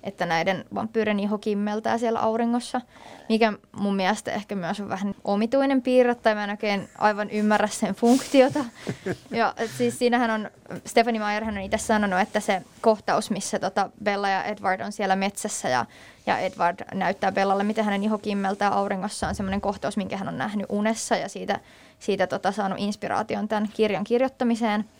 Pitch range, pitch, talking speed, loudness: 200-225 Hz, 210 Hz, 175 wpm, -25 LUFS